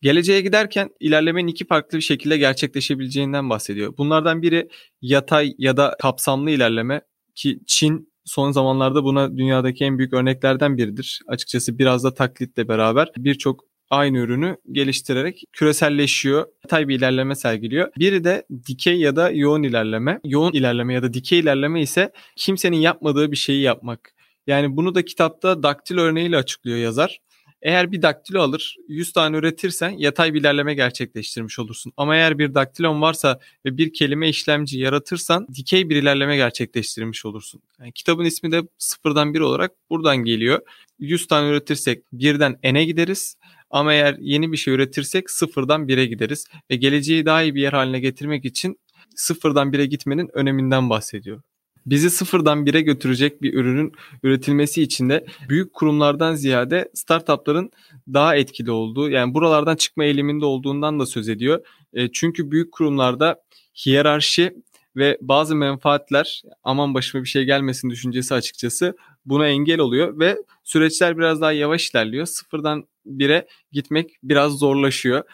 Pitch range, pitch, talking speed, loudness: 130-160 Hz, 145 Hz, 145 wpm, -19 LUFS